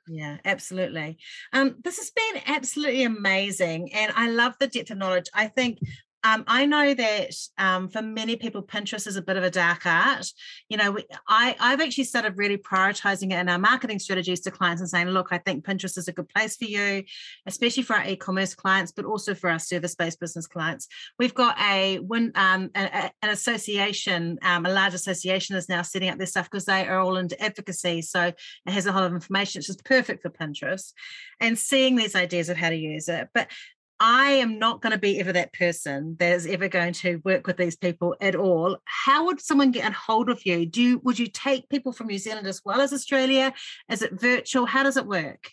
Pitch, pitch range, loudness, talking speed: 195 Hz, 180-240 Hz, -24 LUFS, 220 wpm